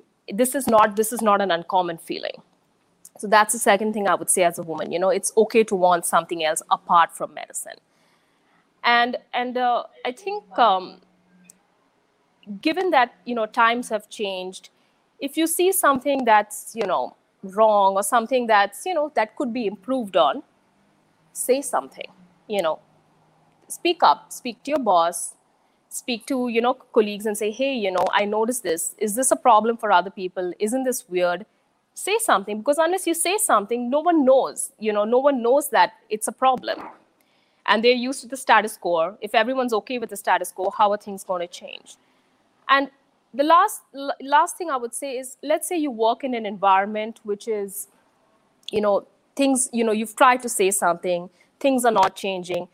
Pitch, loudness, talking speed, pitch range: 225 Hz, -21 LUFS, 190 wpm, 200-265 Hz